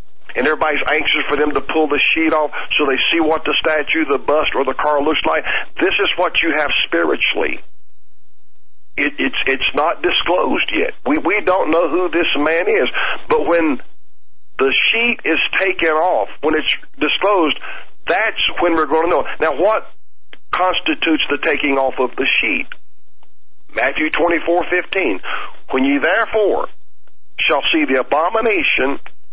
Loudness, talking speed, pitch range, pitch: -16 LUFS, 165 wpm, 150-180 Hz, 160 Hz